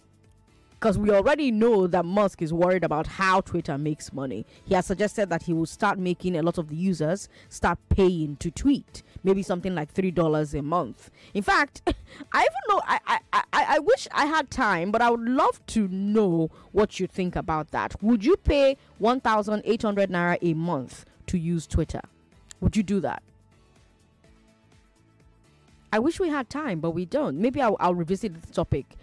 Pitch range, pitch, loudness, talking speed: 165-220 Hz, 185 Hz, -25 LUFS, 180 wpm